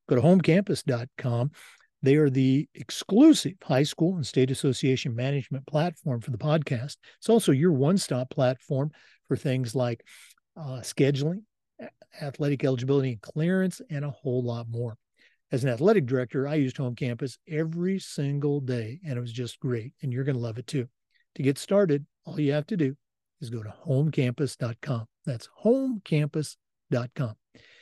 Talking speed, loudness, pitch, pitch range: 160 wpm, -27 LUFS, 140 Hz, 125-155 Hz